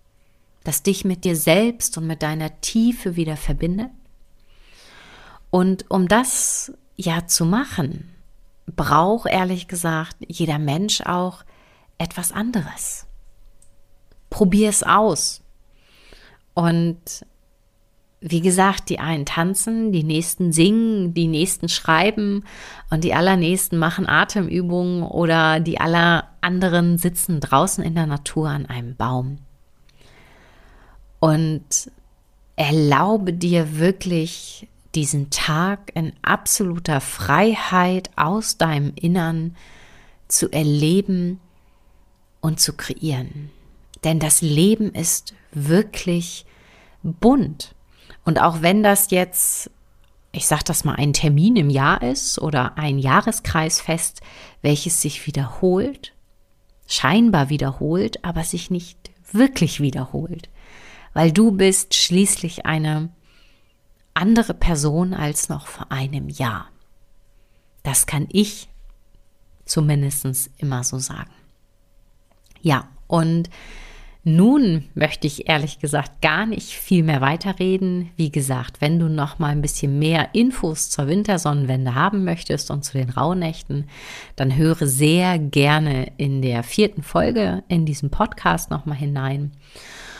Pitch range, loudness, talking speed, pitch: 145-185 Hz, -19 LUFS, 115 wpm, 165 Hz